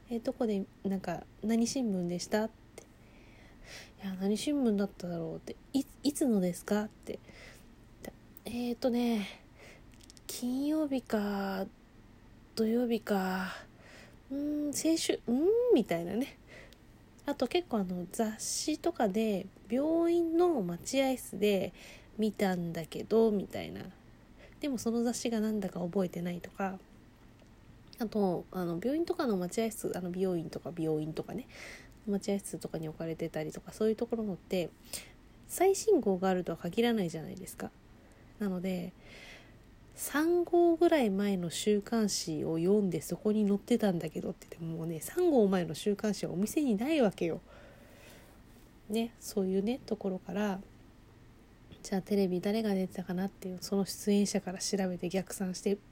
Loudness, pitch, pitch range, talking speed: -33 LUFS, 200 Hz, 175-235 Hz, 285 characters per minute